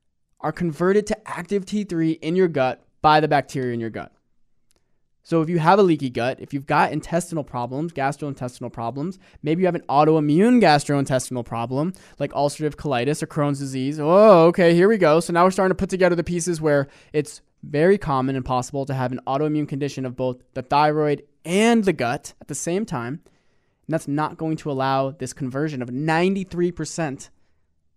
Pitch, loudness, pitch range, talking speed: 150 Hz, -21 LUFS, 135-170 Hz, 185 wpm